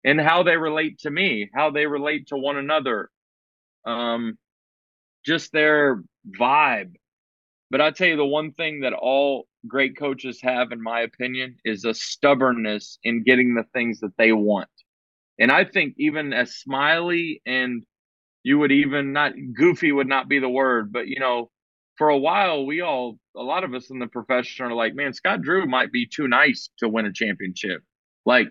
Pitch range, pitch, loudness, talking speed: 115-150 Hz, 130 Hz, -21 LUFS, 185 wpm